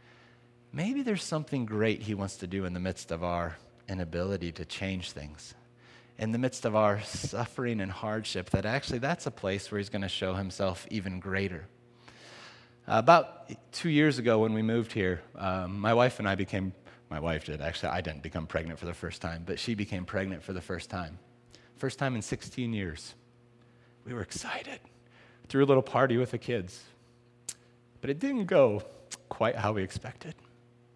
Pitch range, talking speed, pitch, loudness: 95-120 Hz, 185 wpm, 110 Hz, -31 LUFS